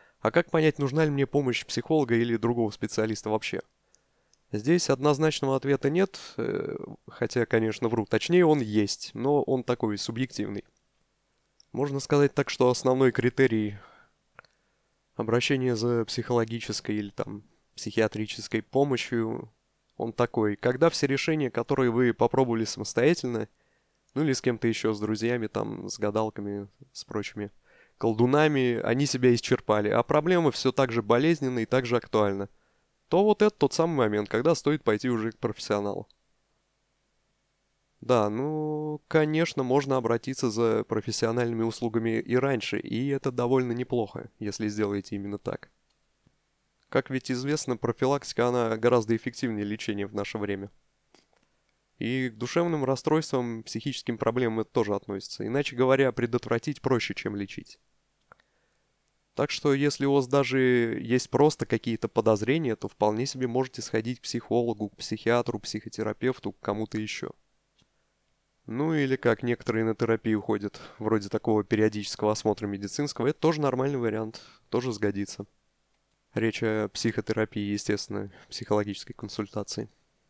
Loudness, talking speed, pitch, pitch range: -27 LUFS, 135 wpm, 120 Hz, 110-135 Hz